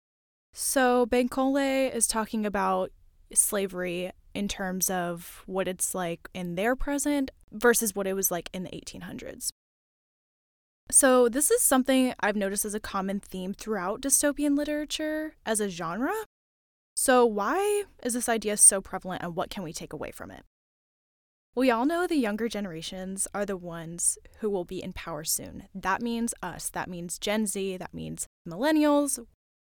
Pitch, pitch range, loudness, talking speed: 210 Hz, 185-260 Hz, -27 LUFS, 160 wpm